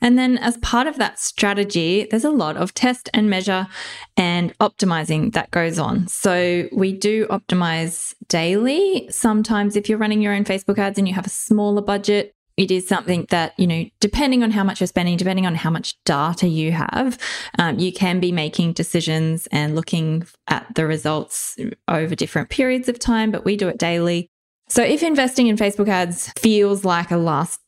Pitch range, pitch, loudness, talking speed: 175-215 Hz, 195 Hz, -19 LUFS, 190 wpm